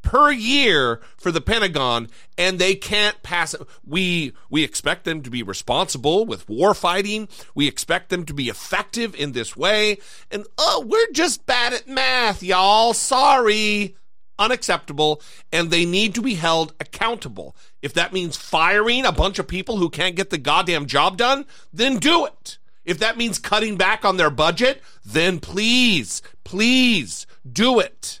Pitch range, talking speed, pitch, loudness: 165-230 Hz, 160 wpm, 195 Hz, -19 LUFS